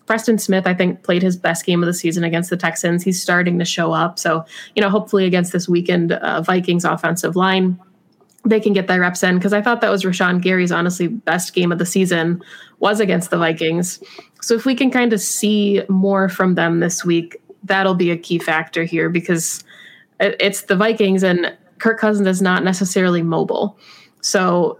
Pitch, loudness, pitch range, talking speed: 185 Hz, -17 LUFS, 175-200 Hz, 205 wpm